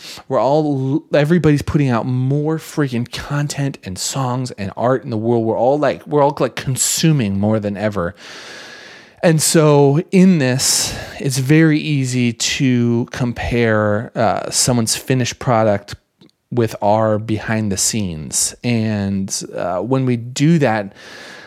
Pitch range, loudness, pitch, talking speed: 110-145 Hz, -17 LUFS, 125 Hz, 135 wpm